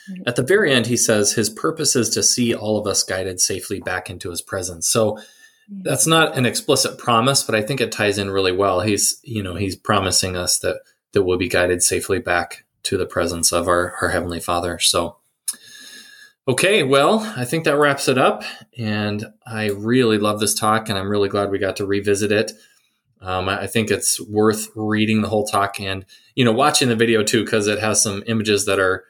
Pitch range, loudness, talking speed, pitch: 100-115 Hz, -19 LUFS, 210 wpm, 105 Hz